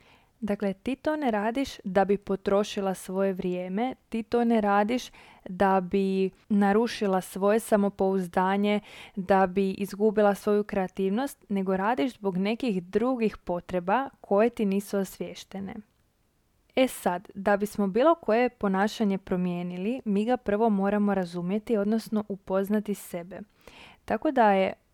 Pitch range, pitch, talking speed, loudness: 195-220 Hz, 205 Hz, 130 wpm, -27 LUFS